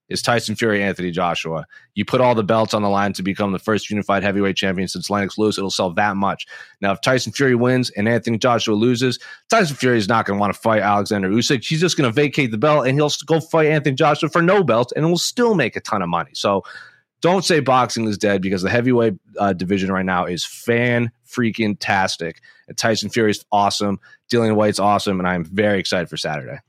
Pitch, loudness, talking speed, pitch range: 110 Hz, -18 LUFS, 225 wpm, 100-125 Hz